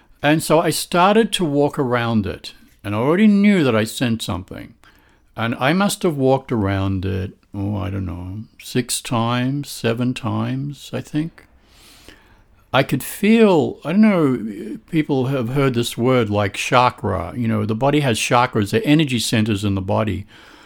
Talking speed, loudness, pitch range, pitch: 170 wpm, -19 LUFS, 110-145 Hz, 125 Hz